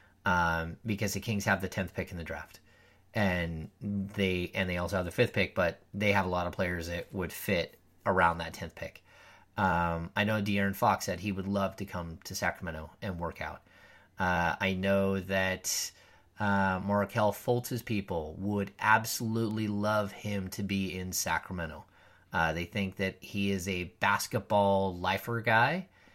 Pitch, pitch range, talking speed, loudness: 95 Hz, 90-105 Hz, 175 wpm, -31 LUFS